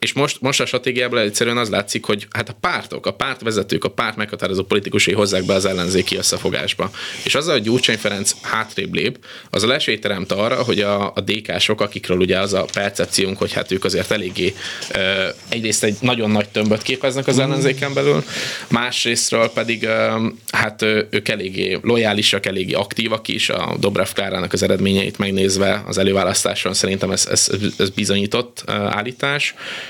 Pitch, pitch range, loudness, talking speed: 110 Hz, 100-120 Hz, -18 LUFS, 160 wpm